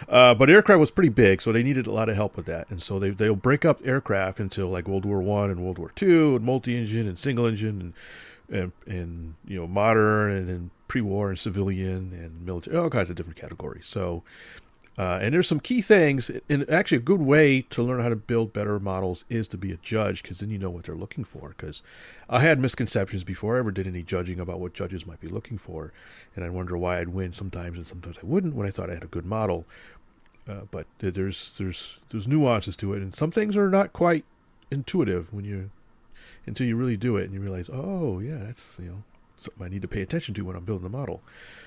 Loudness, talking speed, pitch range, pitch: -25 LUFS, 235 wpm, 90-125 Hz, 100 Hz